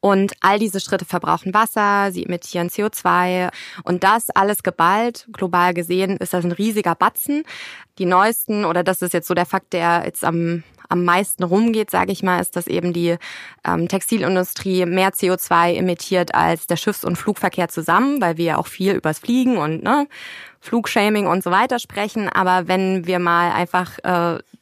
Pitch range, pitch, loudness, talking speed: 175-205 Hz, 185 Hz, -19 LUFS, 180 wpm